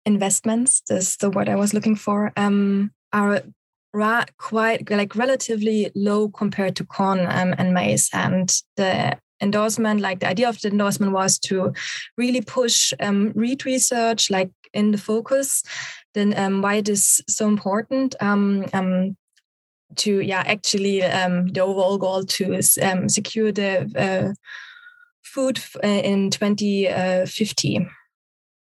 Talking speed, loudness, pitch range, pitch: 135 wpm, -20 LUFS, 190-220 Hz, 205 Hz